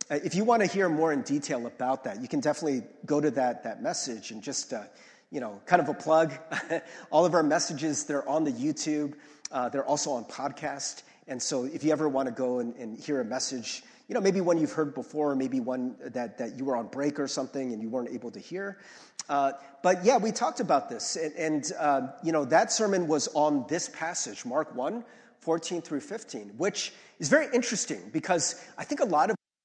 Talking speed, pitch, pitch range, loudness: 220 wpm, 155 Hz, 140-195 Hz, -29 LUFS